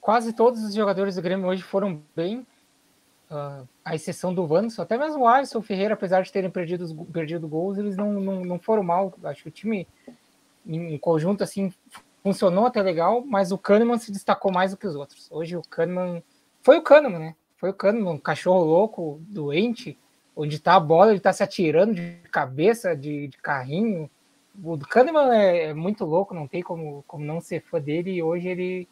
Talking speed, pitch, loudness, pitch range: 200 wpm, 185 Hz, -23 LUFS, 165-205 Hz